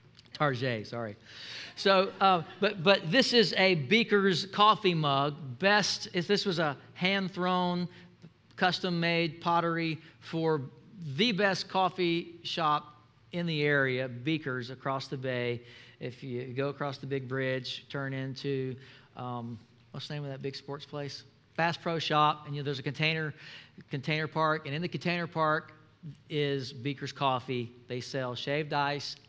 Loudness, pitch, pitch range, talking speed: -30 LUFS, 150 Hz, 135-170 Hz, 155 wpm